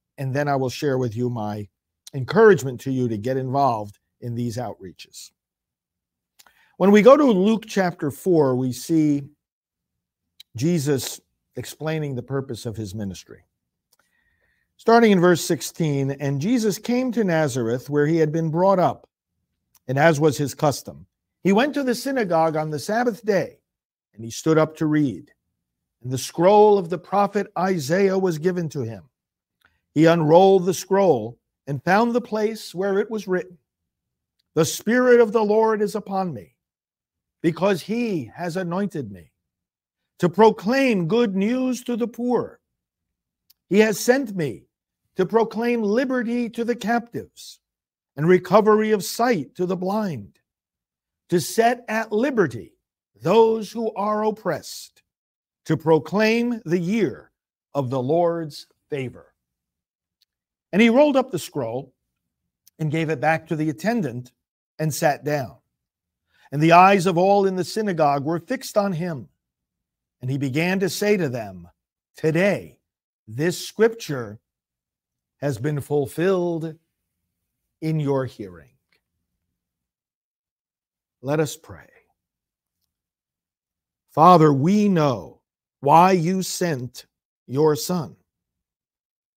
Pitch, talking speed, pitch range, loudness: 160 Hz, 135 wpm, 130-205 Hz, -21 LUFS